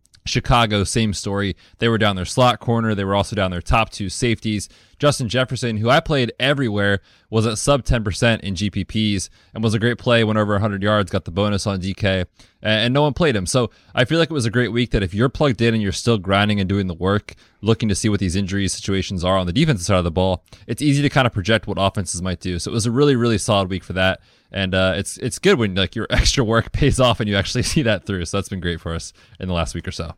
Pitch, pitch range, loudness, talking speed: 105 Hz, 95-120 Hz, -19 LUFS, 270 wpm